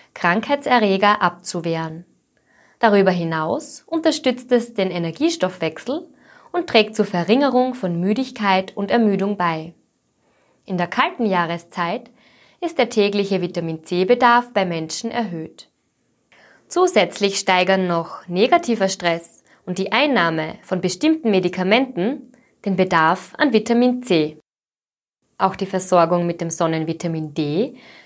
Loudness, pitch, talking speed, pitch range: -19 LUFS, 190 Hz, 105 wpm, 170-240 Hz